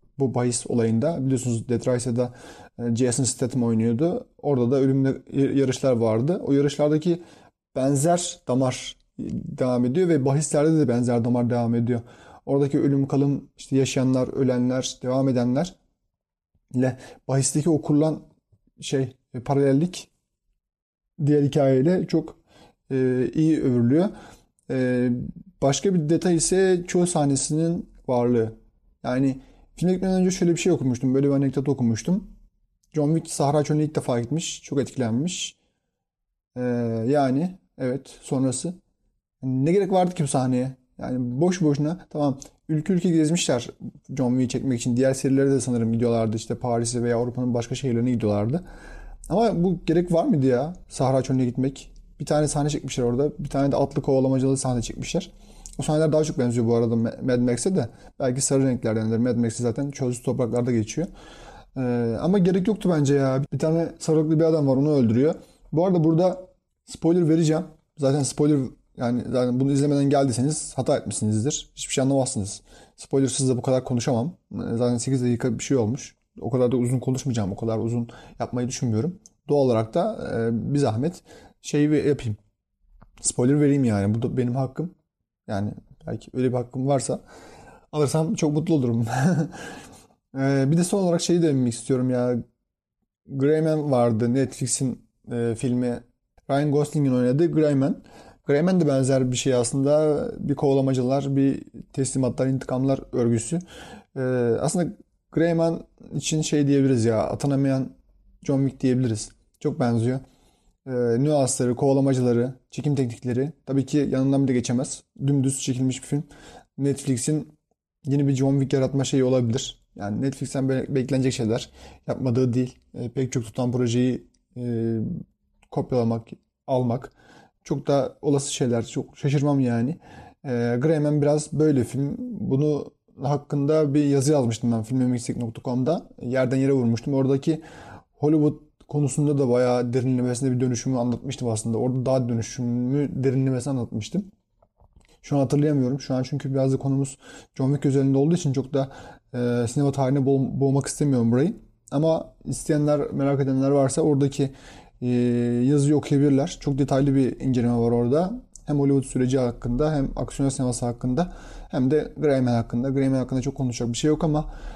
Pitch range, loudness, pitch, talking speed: 125-150 Hz, -23 LUFS, 135 Hz, 145 wpm